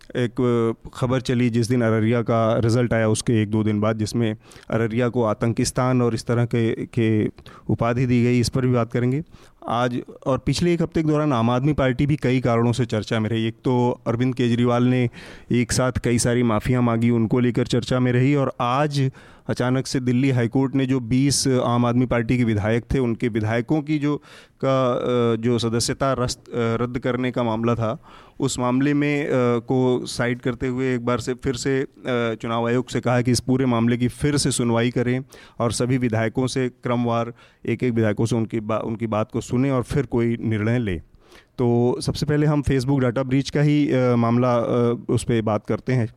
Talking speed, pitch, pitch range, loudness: 200 wpm, 125 Hz, 115-130 Hz, -21 LUFS